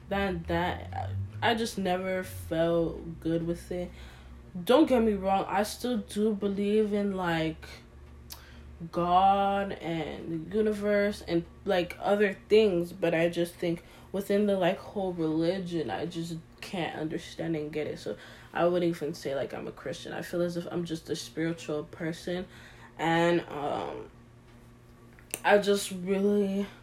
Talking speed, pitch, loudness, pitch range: 145 wpm, 175 Hz, -30 LUFS, 160-200 Hz